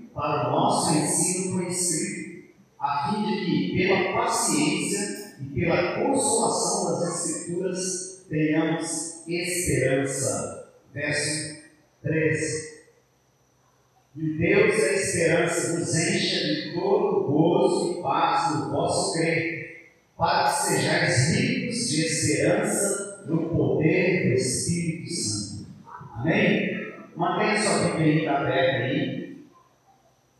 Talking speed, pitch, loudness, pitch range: 105 wpm, 165 Hz, -24 LUFS, 155-180 Hz